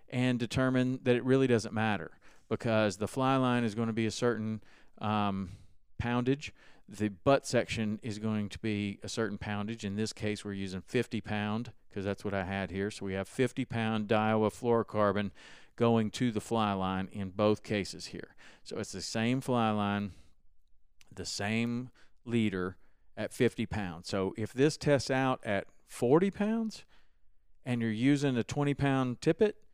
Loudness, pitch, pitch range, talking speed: -32 LUFS, 110 Hz, 100-125 Hz, 170 wpm